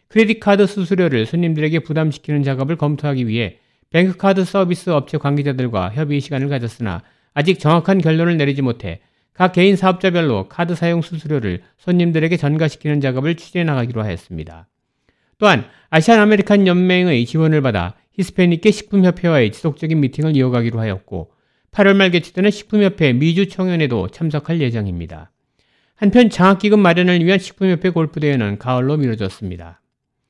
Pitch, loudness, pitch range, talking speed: 155 Hz, -16 LUFS, 125-180 Hz, 400 characters per minute